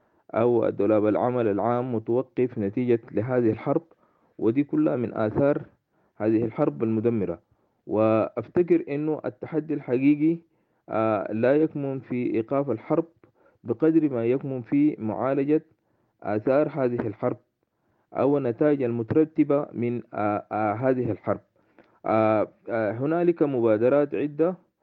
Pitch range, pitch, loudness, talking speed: 110-150 Hz, 125 Hz, -25 LUFS, 105 wpm